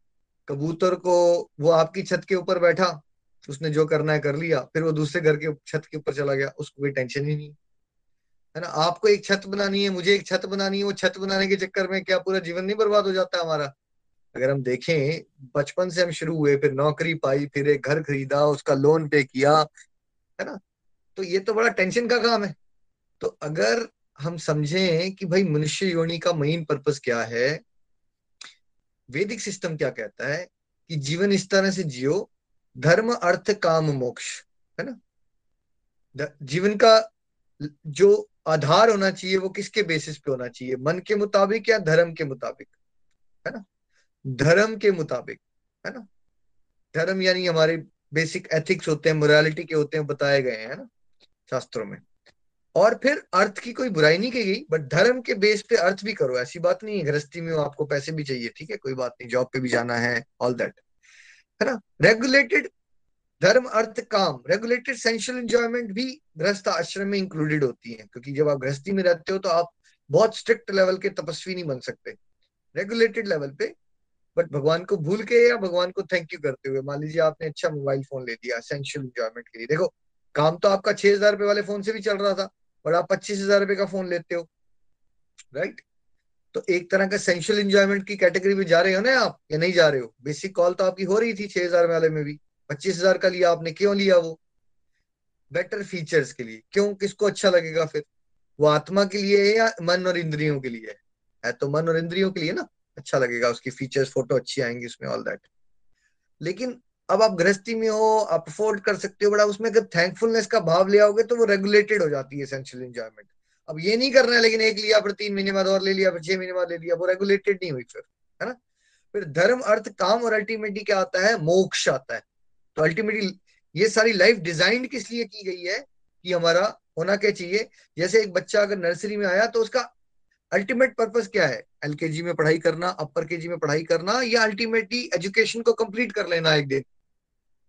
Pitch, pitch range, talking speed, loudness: 180 Hz, 150-205 Hz, 200 wpm, -23 LUFS